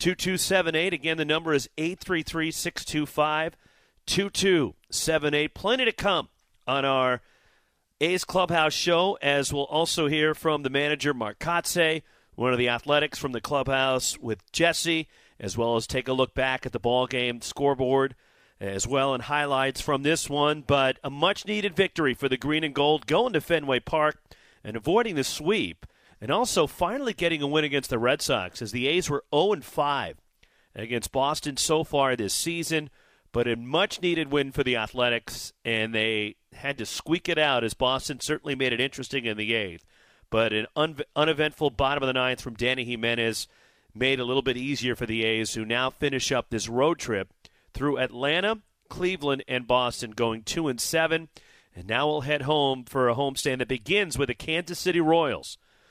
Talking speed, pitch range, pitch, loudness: 180 wpm, 125-155 Hz, 140 Hz, -26 LUFS